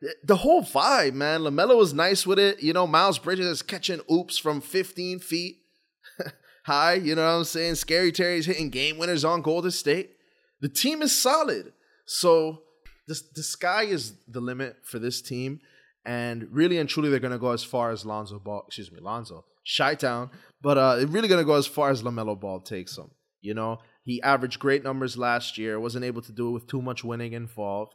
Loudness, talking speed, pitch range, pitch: -25 LUFS, 205 wpm, 120-170 Hz, 145 Hz